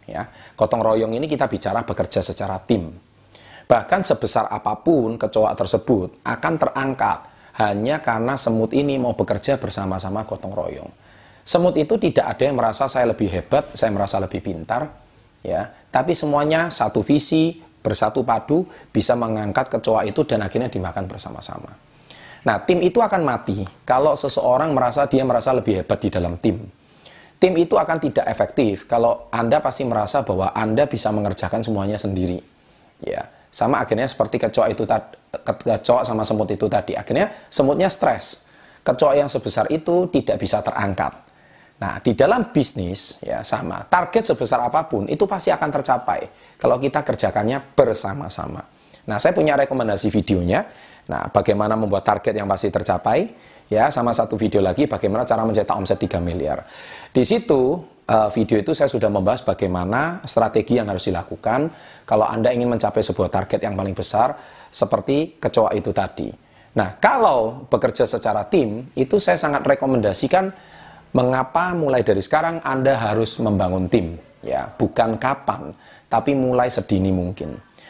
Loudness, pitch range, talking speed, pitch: -20 LUFS, 100-140 Hz, 150 wpm, 115 Hz